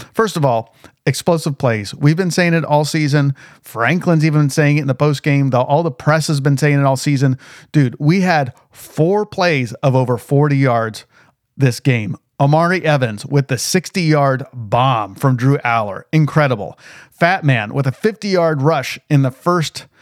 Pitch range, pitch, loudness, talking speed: 130-160 Hz, 145 Hz, -16 LUFS, 175 wpm